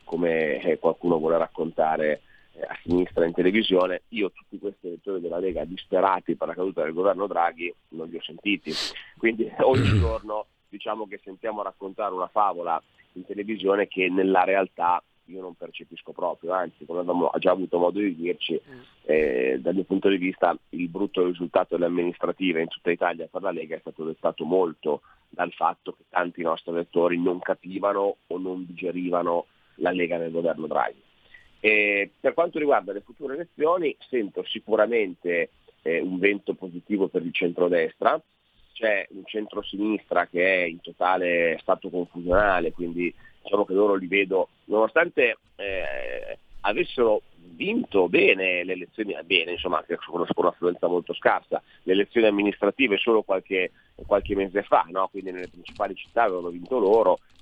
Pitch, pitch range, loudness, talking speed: 95 Hz, 85-100 Hz, -25 LUFS, 155 wpm